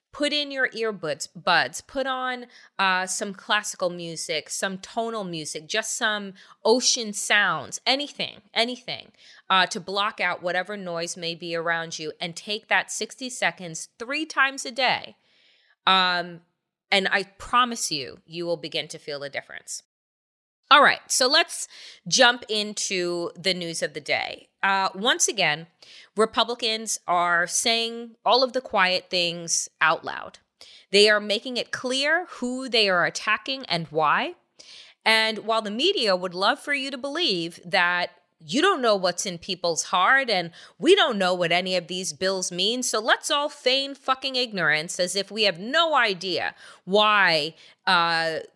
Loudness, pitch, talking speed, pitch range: -23 LUFS, 200 Hz, 160 wpm, 175-245 Hz